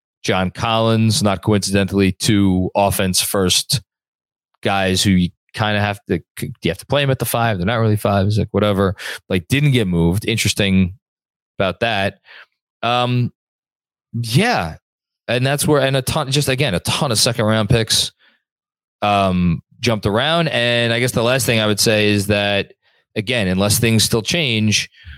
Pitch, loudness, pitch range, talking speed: 110 Hz, -17 LUFS, 100-120 Hz, 165 wpm